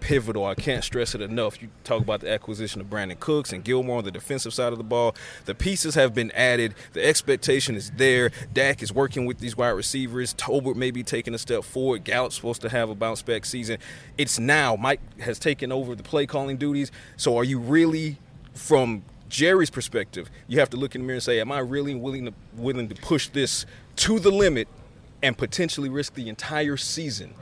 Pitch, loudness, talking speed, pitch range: 125 Hz, -25 LUFS, 215 wpm, 115-140 Hz